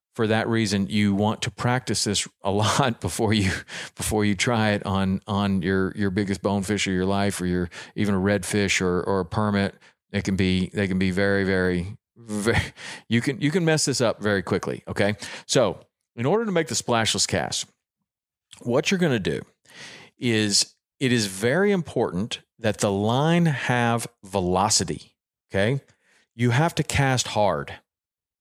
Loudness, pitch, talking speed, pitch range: -23 LUFS, 105 Hz, 175 wpm, 100-120 Hz